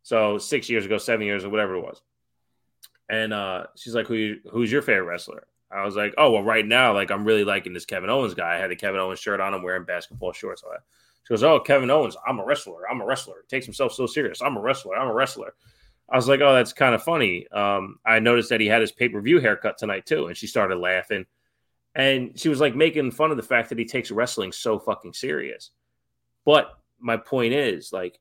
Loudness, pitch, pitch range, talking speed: -23 LUFS, 110 Hz, 100-125 Hz, 245 wpm